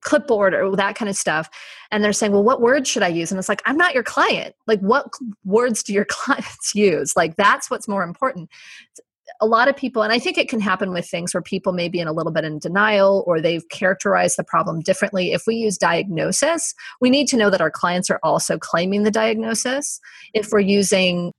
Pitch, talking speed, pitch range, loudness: 205 Hz, 230 wpm, 185-230 Hz, -19 LUFS